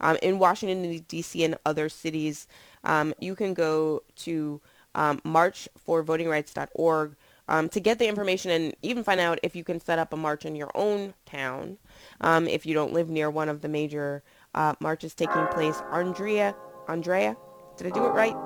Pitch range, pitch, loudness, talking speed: 155-175 Hz, 160 Hz, -27 LUFS, 180 wpm